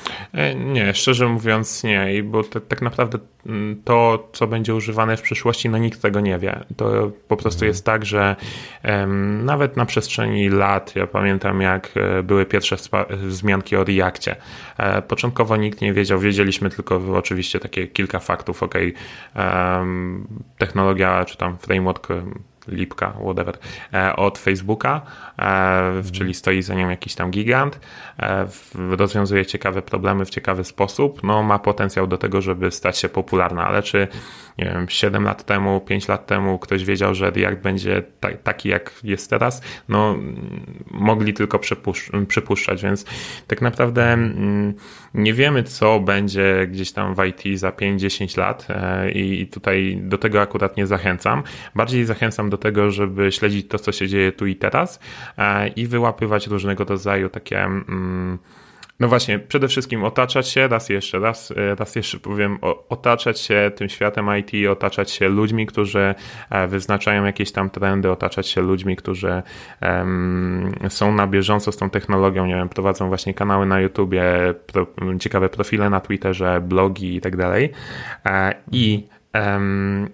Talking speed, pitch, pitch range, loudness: 145 wpm, 100 Hz, 95-110 Hz, -20 LUFS